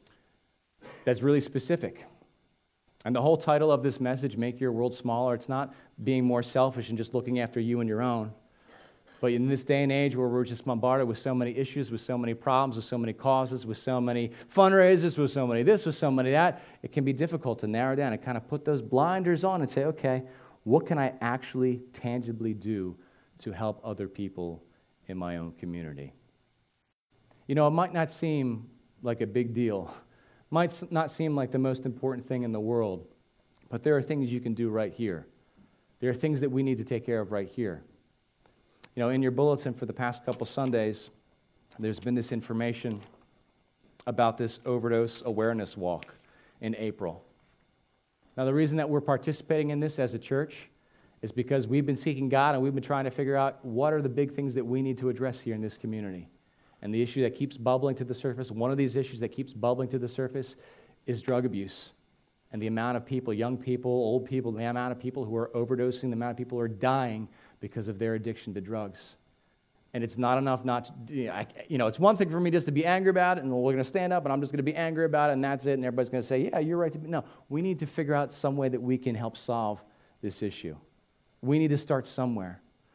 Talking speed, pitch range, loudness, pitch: 225 wpm, 115-140 Hz, -29 LUFS, 125 Hz